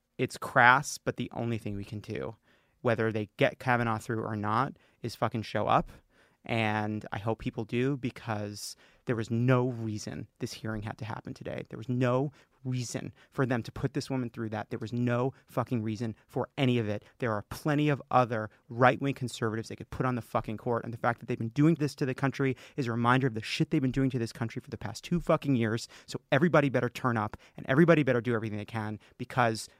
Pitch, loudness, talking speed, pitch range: 120 Hz, -30 LUFS, 230 wpm, 110-130 Hz